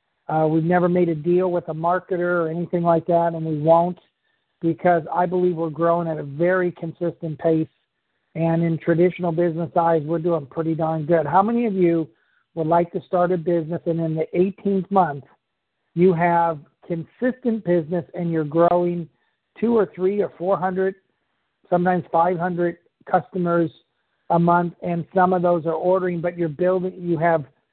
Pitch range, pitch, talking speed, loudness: 165-180 Hz, 175 Hz, 170 wpm, -21 LUFS